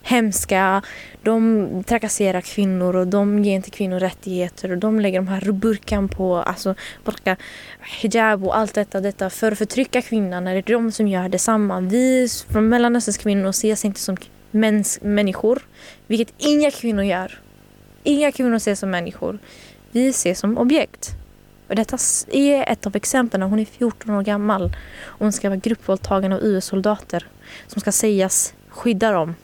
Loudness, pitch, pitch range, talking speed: -20 LUFS, 210 Hz, 190-225 Hz, 160 wpm